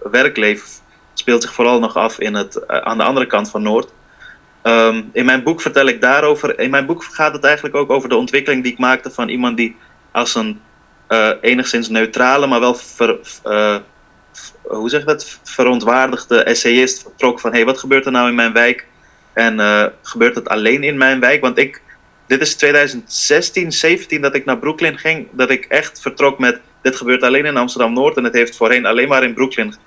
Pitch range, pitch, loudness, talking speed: 115-135 Hz, 125 Hz, -14 LUFS, 200 wpm